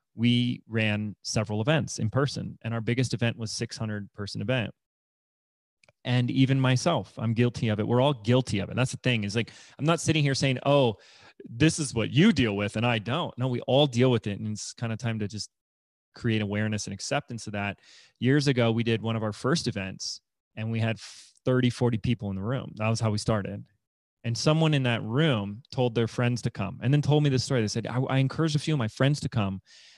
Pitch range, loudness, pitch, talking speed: 110-130 Hz, -27 LUFS, 120 Hz, 230 wpm